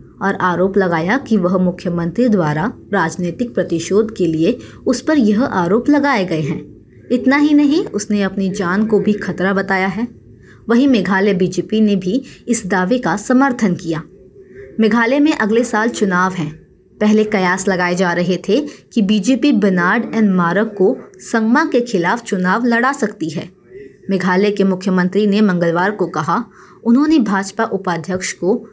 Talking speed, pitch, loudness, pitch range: 155 wpm, 205 Hz, -16 LUFS, 185-235 Hz